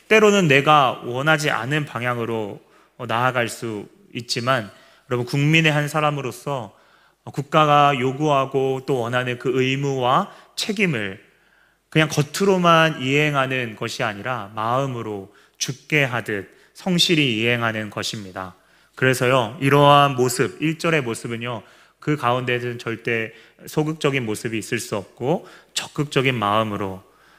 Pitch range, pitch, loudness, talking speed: 115-145 Hz, 130 Hz, -20 LUFS, 280 characters per minute